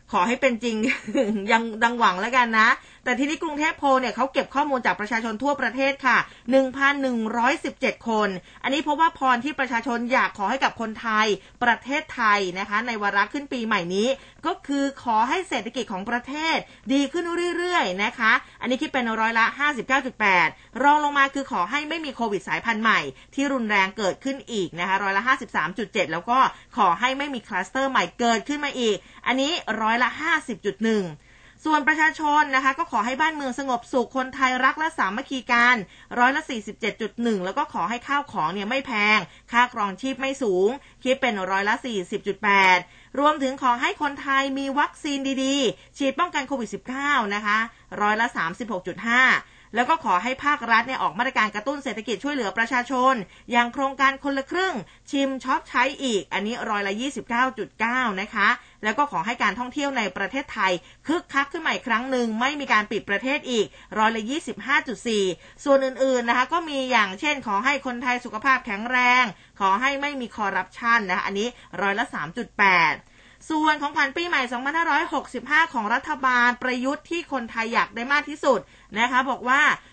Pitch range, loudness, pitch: 215-275 Hz, -23 LUFS, 250 Hz